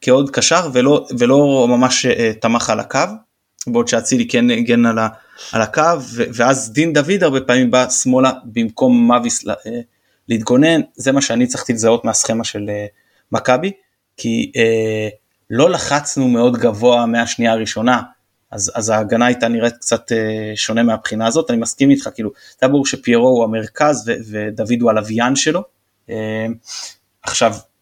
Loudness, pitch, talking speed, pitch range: -15 LUFS, 120 Hz, 155 wpm, 115-135 Hz